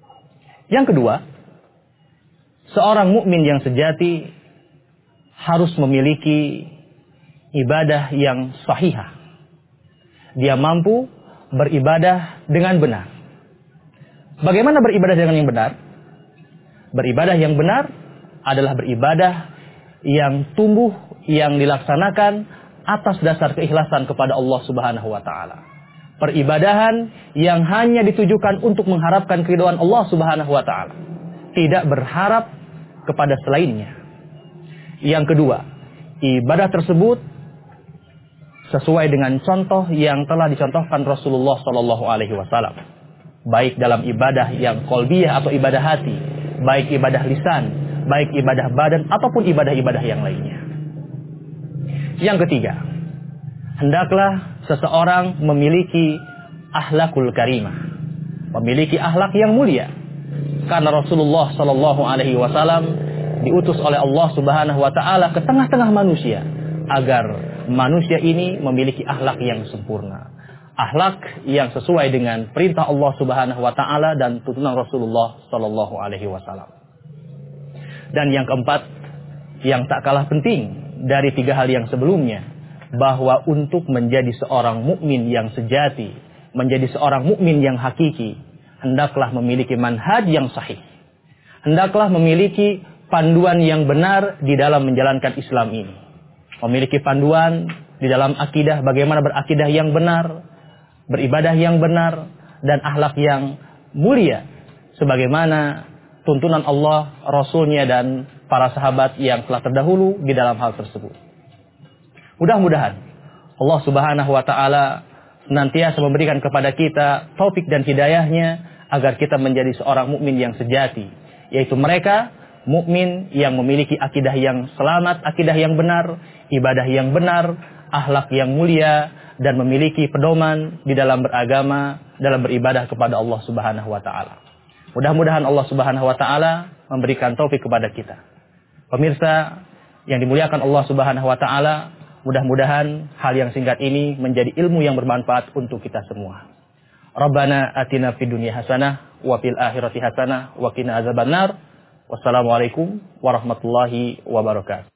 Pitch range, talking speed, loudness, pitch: 135-165 Hz, 115 wpm, -17 LUFS, 150 Hz